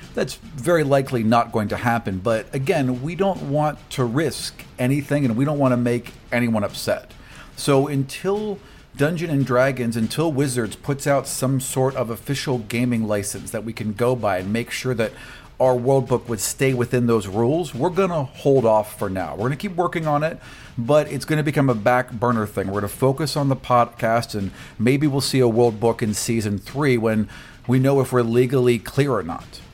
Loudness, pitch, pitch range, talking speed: -21 LUFS, 125 Hz, 115-140 Hz, 210 wpm